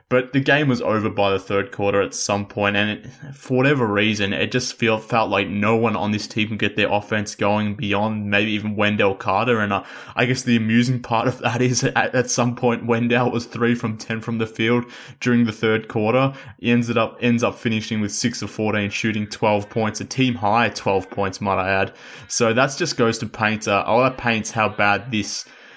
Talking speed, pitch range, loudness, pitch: 220 wpm, 105-120 Hz, -20 LUFS, 110 Hz